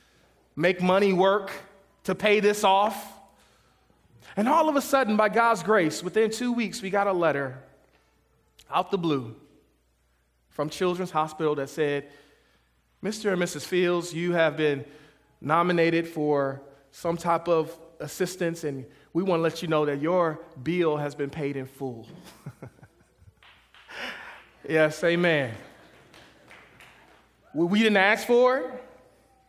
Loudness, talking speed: -25 LUFS, 135 wpm